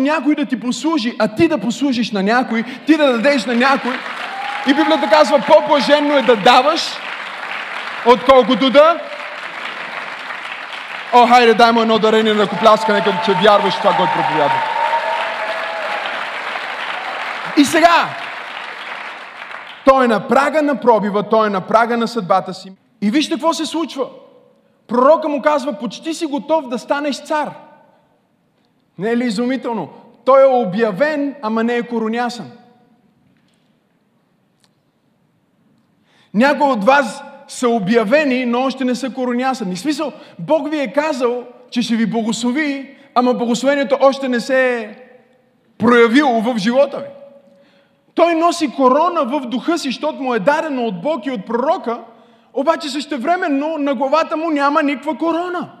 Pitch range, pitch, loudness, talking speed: 235-295 Hz, 265 Hz, -16 LUFS, 140 wpm